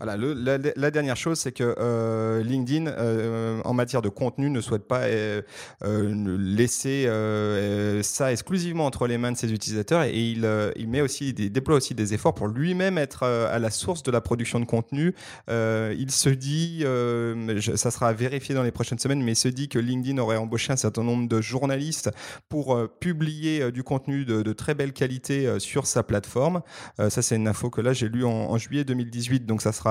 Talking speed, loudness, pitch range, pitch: 220 wpm, -25 LUFS, 110-140 Hz, 120 Hz